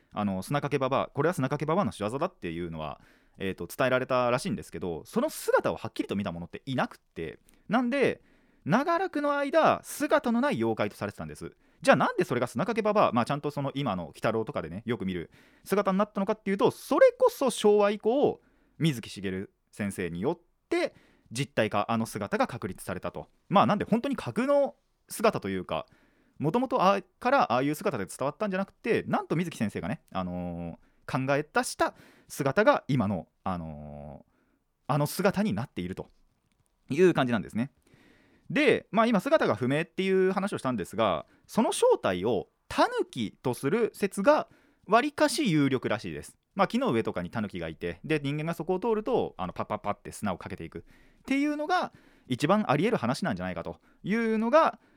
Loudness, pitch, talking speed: -28 LUFS, 150 Hz, 380 characters per minute